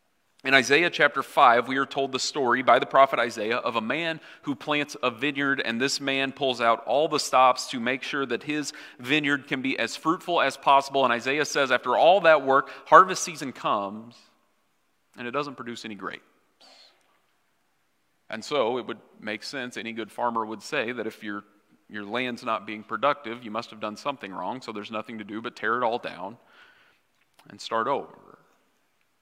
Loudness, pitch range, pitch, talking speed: -24 LUFS, 115-140 Hz, 130 Hz, 195 wpm